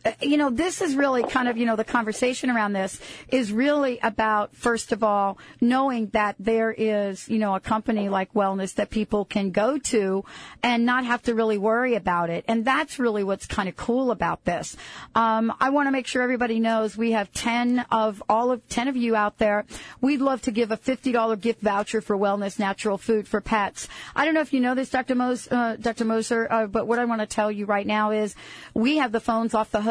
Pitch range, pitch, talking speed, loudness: 215-250 Hz, 225 Hz, 230 wpm, -24 LUFS